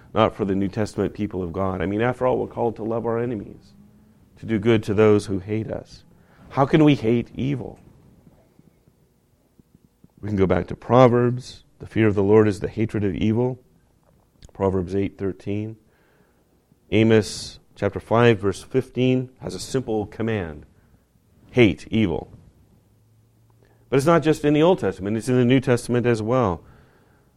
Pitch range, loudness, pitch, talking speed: 100-120 Hz, -21 LUFS, 110 Hz, 165 wpm